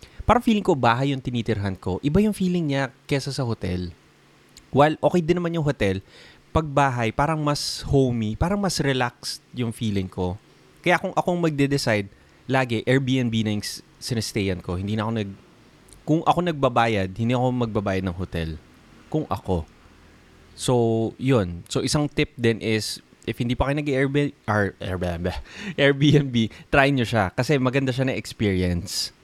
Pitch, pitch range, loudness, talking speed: 125 Hz, 100-145 Hz, -23 LUFS, 160 wpm